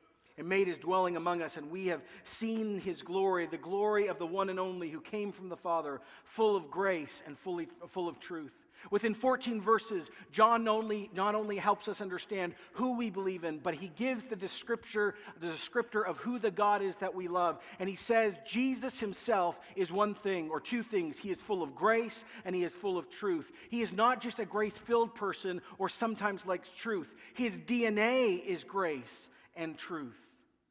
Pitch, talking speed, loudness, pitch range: 200 Hz, 195 wpm, -34 LUFS, 180-225 Hz